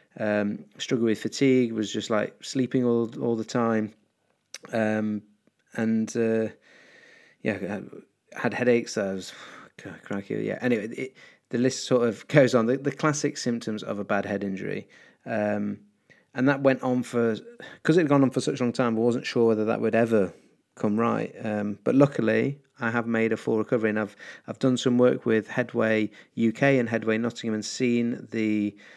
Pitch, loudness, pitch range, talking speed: 115 Hz, -26 LUFS, 110-125 Hz, 185 wpm